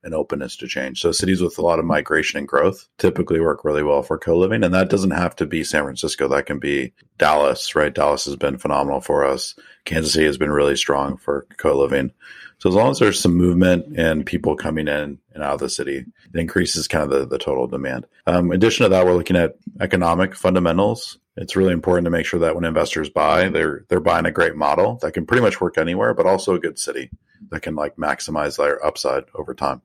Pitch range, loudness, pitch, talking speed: 75-90 Hz, -19 LUFS, 85 Hz, 230 wpm